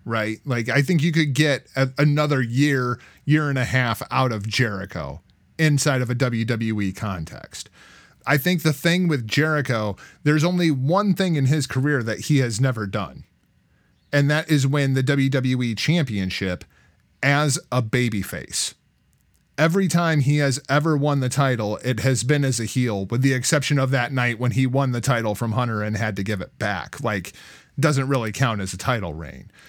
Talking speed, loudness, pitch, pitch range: 185 wpm, -22 LUFS, 130 Hz, 110-145 Hz